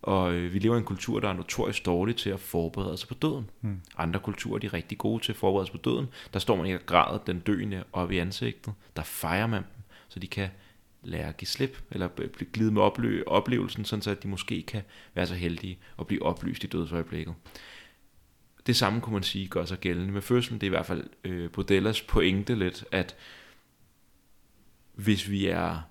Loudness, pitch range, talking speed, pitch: -30 LUFS, 90-110 Hz, 210 wpm, 100 Hz